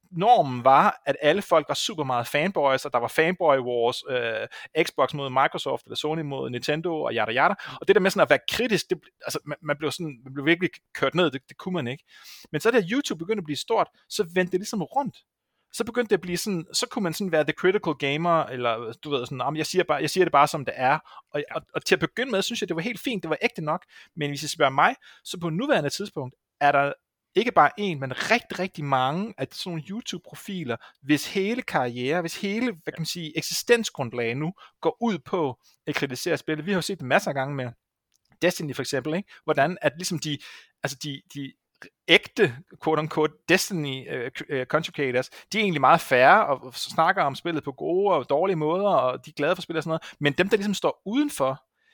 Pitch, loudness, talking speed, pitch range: 160 Hz, -25 LUFS, 235 wpm, 140-190 Hz